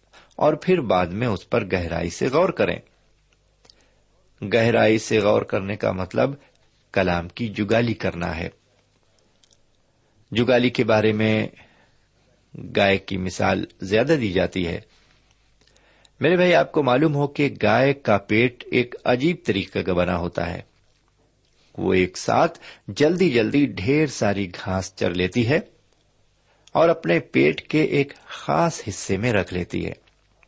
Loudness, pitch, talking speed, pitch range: -21 LUFS, 110 Hz, 140 wpm, 95-125 Hz